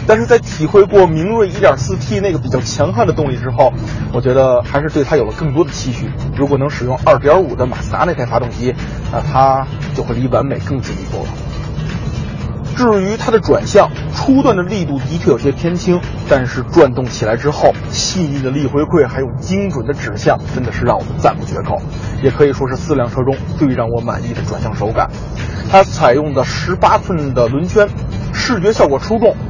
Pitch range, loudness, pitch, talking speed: 125-165 Hz, -14 LUFS, 140 Hz, 305 characters per minute